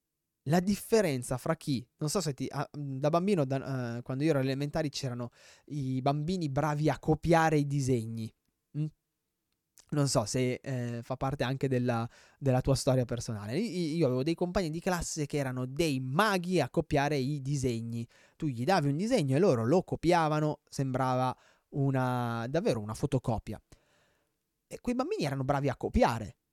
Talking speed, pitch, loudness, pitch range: 165 wpm, 140 Hz, -31 LUFS, 130-155 Hz